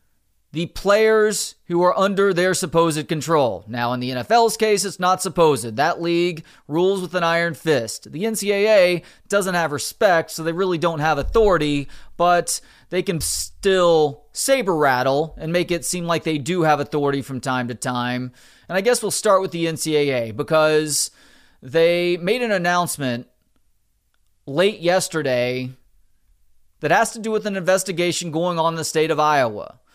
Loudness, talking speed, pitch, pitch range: -20 LUFS, 165 wpm, 165 Hz, 140-185 Hz